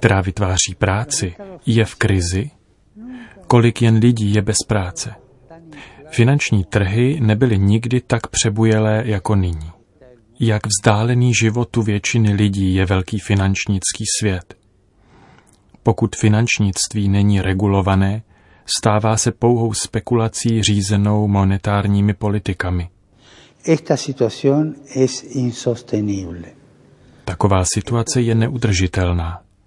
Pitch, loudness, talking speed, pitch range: 110 Hz, -17 LUFS, 90 wpm, 100-120 Hz